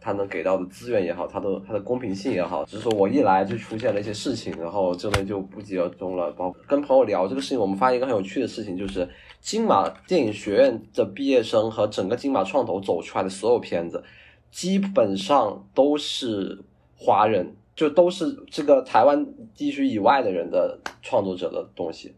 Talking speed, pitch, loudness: 320 characters per minute, 135 Hz, -23 LUFS